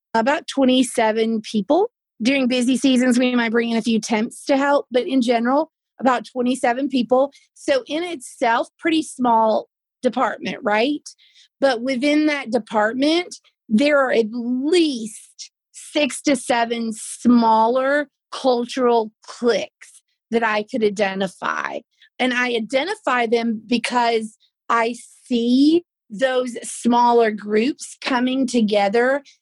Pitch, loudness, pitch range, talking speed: 250 Hz, -20 LUFS, 230-275 Hz, 120 wpm